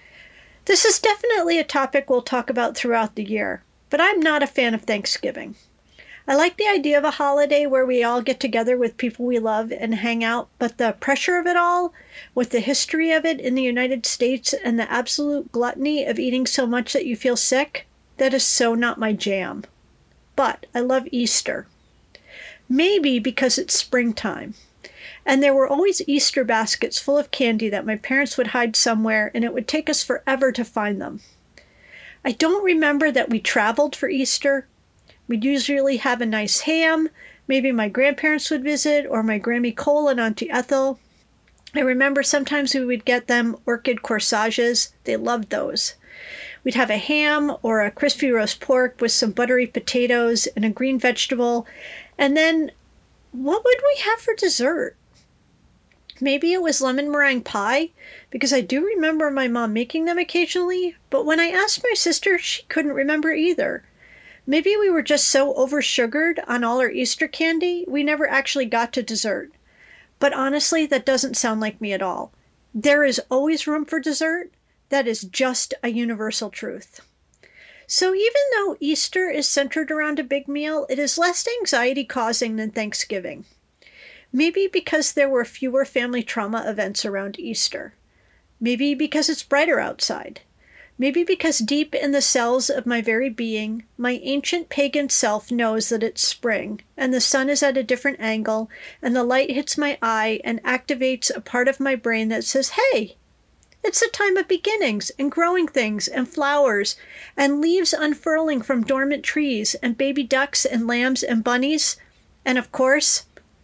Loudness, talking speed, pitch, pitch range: -21 LUFS, 175 wpm, 270 Hz, 240-300 Hz